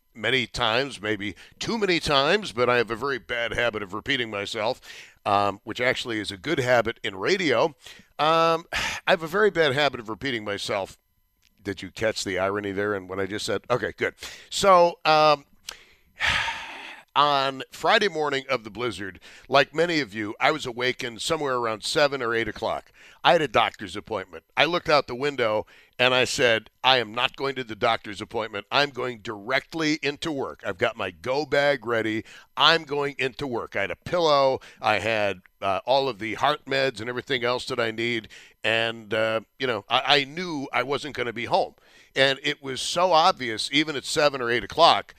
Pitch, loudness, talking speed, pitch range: 125 Hz, -24 LUFS, 195 wpm, 110-145 Hz